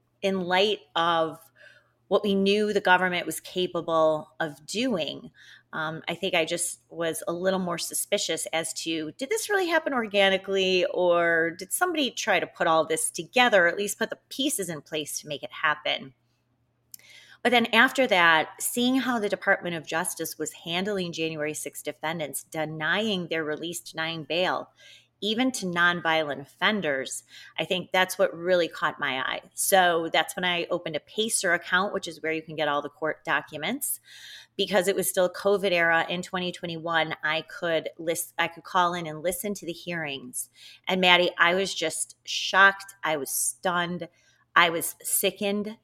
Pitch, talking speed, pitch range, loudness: 170 Hz, 175 wpm, 160-195 Hz, -26 LUFS